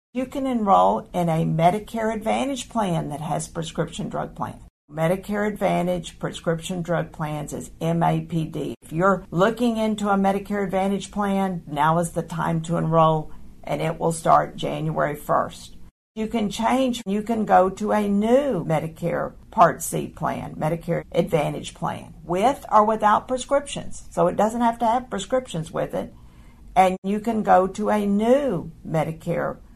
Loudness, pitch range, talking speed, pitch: -23 LUFS, 165-215 Hz, 155 wpm, 185 Hz